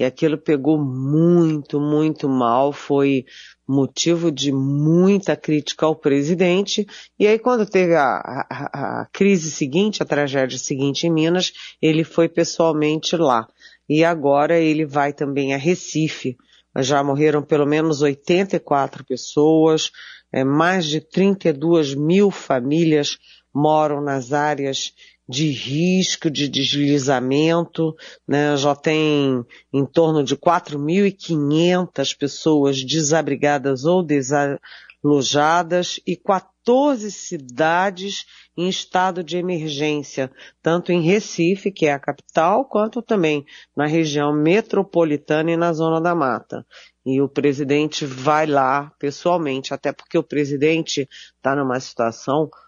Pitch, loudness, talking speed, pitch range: 155 Hz, -19 LUFS, 120 wpm, 140-170 Hz